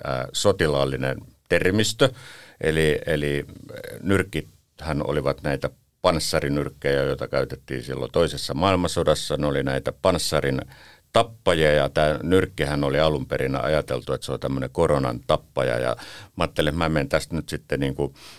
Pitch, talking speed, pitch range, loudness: 75 Hz, 135 wpm, 70-85 Hz, -24 LUFS